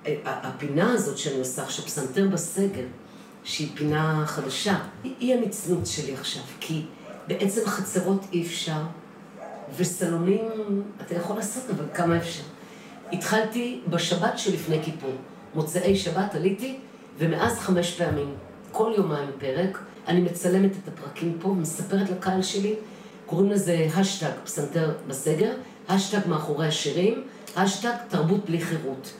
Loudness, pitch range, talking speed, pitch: -26 LUFS, 160-210 Hz, 125 wpm, 185 Hz